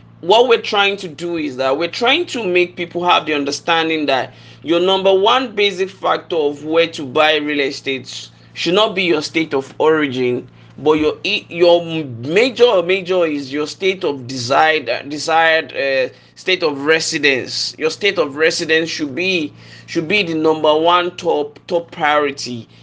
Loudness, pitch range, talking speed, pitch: -16 LUFS, 145-180 Hz, 170 wpm, 160 Hz